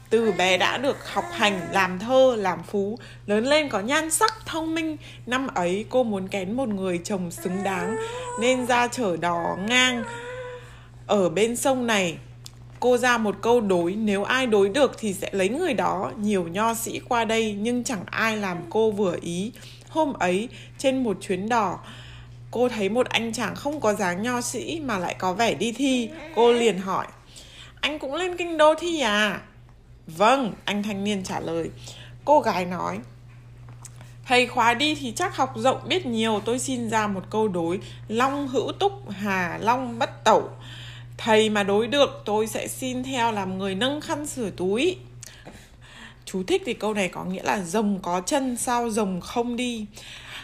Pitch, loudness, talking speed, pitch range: 215 Hz, -24 LUFS, 185 wpm, 180-250 Hz